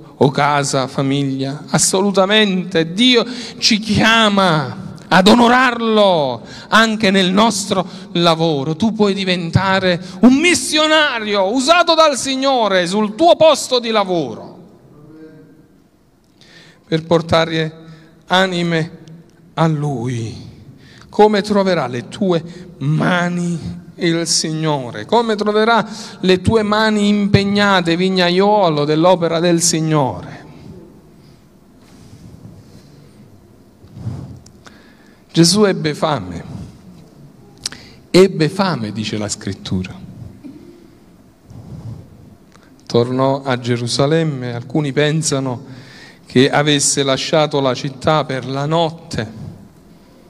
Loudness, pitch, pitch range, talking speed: -15 LUFS, 165 Hz, 145-200 Hz, 80 wpm